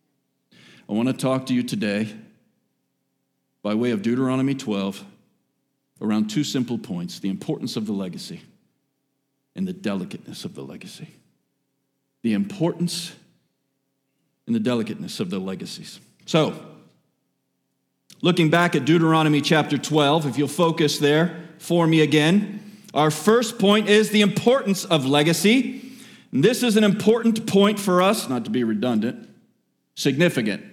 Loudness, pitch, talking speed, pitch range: -21 LUFS, 155 Hz, 135 wpm, 135-195 Hz